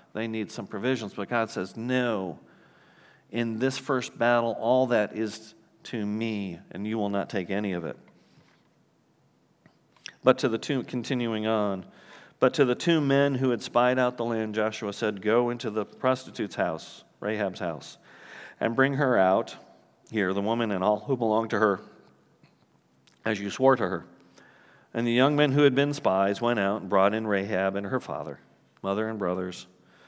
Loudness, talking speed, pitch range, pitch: -27 LUFS, 180 wpm, 100-120 Hz, 110 Hz